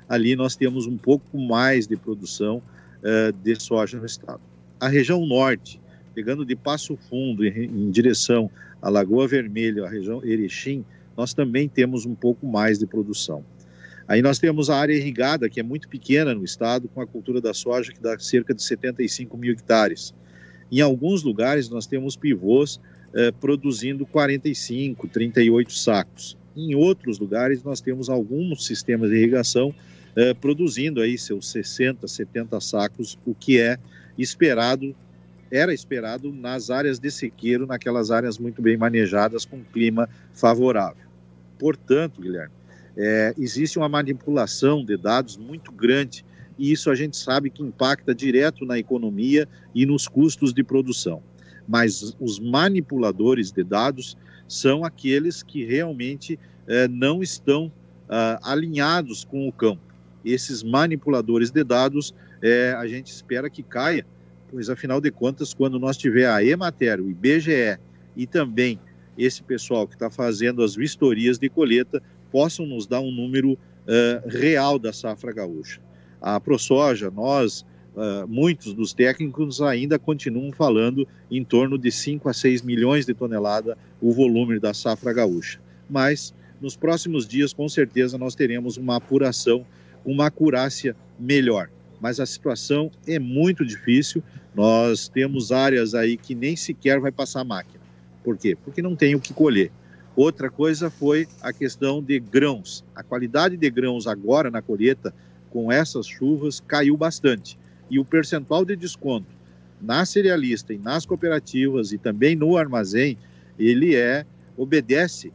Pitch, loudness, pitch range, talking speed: 125 Hz, -22 LUFS, 110-140 Hz, 150 wpm